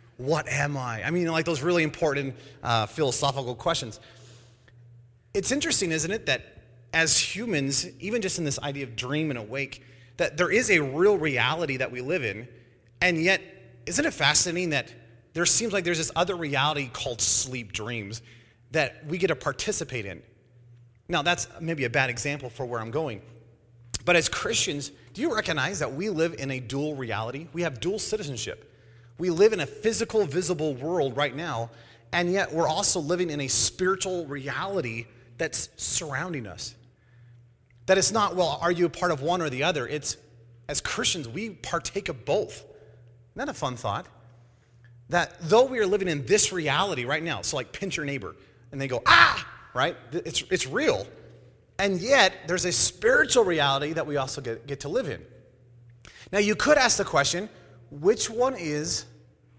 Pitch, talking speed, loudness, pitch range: 145 Hz, 180 wpm, -24 LUFS, 120-175 Hz